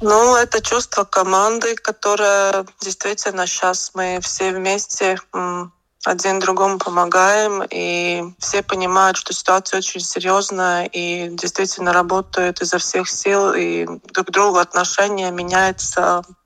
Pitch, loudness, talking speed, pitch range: 190 Hz, -17 LUFS, 115 wpm, 180-200 Hz